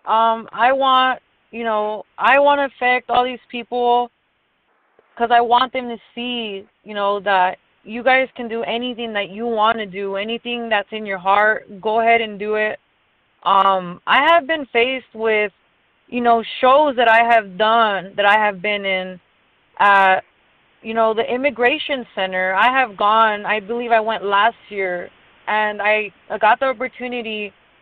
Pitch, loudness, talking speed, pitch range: 225 Hz, -17 LUFS, 175 wpm, 205-245 Hz